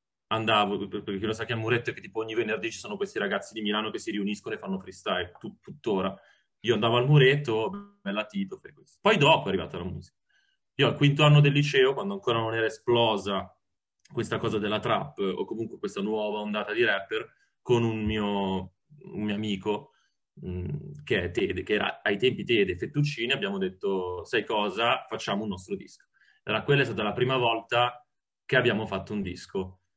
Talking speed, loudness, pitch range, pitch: 195 wpm, -27 LUFS, 105-145 Hz, 110 Hz